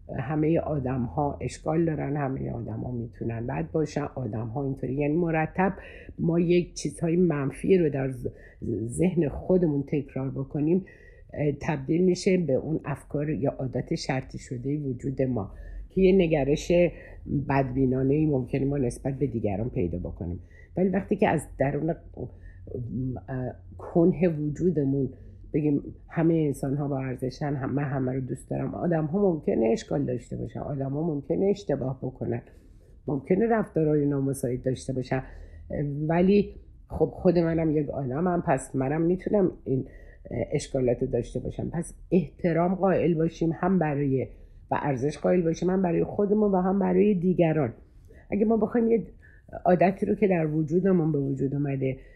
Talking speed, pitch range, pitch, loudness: 145 wpm, 130-170 Hz, 145 Hz, -27 LUFS